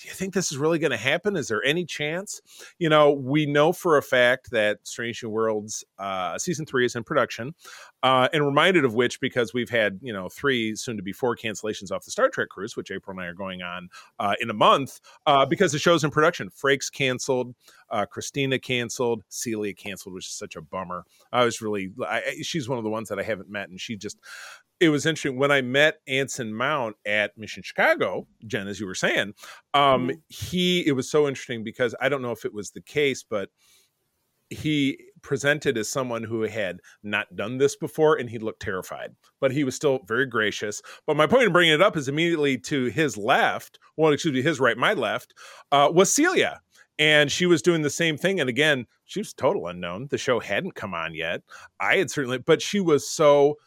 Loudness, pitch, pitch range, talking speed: -24 LUFS, 135 Hz, 115-155 Hz, 220 wpm